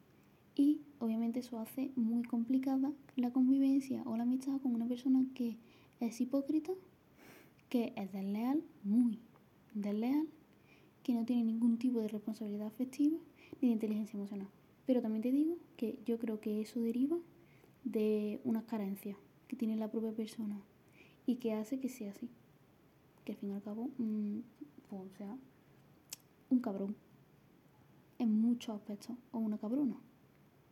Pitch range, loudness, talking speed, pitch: 220-260 Hz, -37 LUFS, 150 wpm, 235 Hz